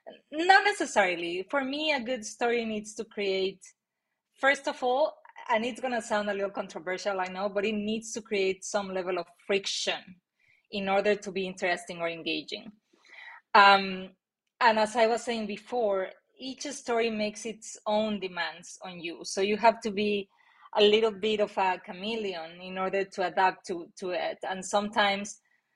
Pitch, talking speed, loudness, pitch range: 205 Hz, 170 wpm, -28 LUFS, 190-230 Hz